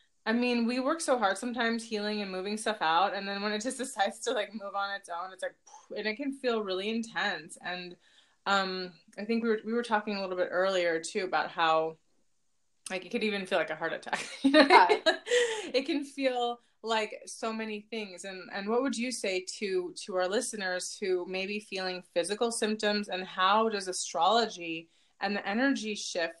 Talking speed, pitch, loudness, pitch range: 210 wpm, 210 Hz, -30 LUFS, 185-240 Hz